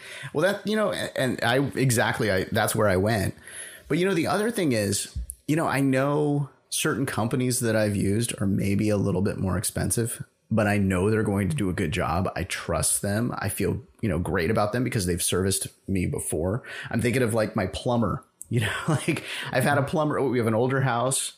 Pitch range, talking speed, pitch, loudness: 100-130 Hz, 220 wpm, 115 Hz, -25 LUFS